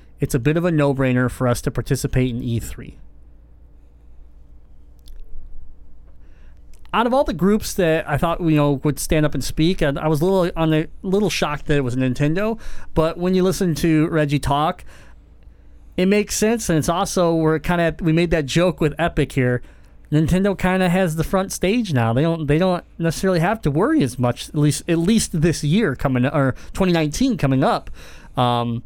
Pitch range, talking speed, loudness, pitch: 125-175 Hz, 200 wpm, -19 LUFS, 150 Hz